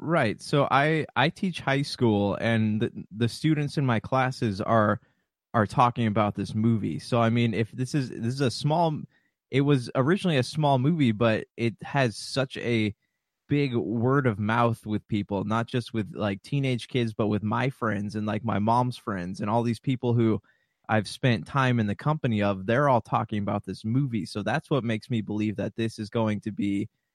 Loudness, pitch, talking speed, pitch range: -26 LUFS, 115 Hz, 205 wpm, 110-135 Hz